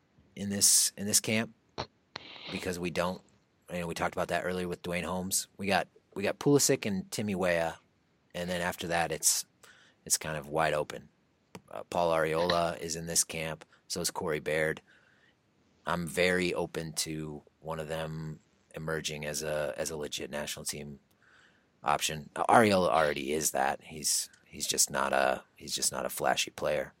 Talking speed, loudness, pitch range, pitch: 180 wpm, -30 LUFS, 80-90 Hz, 85 Hz